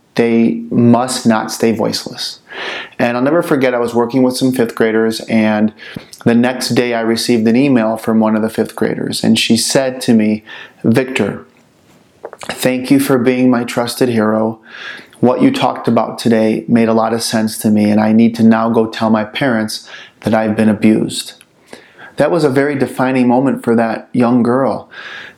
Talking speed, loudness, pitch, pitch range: 185 wpm, -13 LUFS, 115 Hz, 110-125 Hz